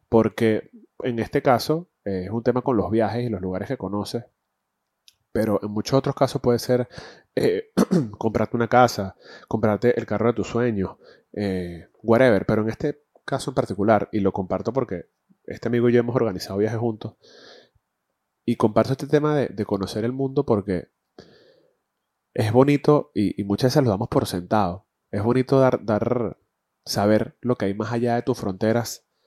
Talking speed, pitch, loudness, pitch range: 175 wpm, 115 Hz, -23 LUFS, 105-130 Hz